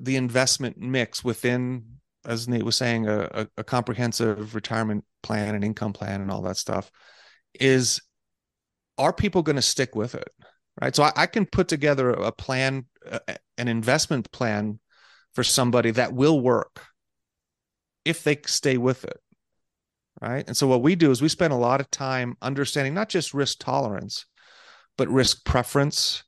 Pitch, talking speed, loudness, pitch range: 125 Hz, 165 wpm, -24 LUFS, 115-135 Hz